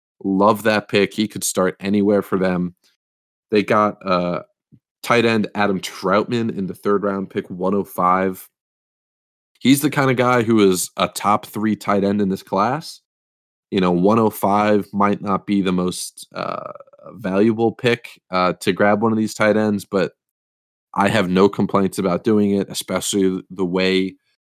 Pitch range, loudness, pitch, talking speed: 95-105 Hz, -19 LUFS, 100 Hz, 165 wpm